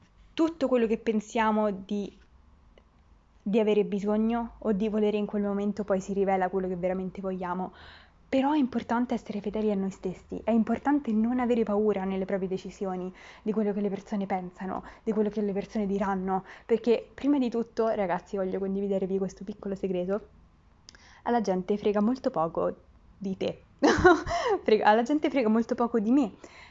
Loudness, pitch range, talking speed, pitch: -28 LUFS, 190-230 Hz, 165 wpm, 210 Hz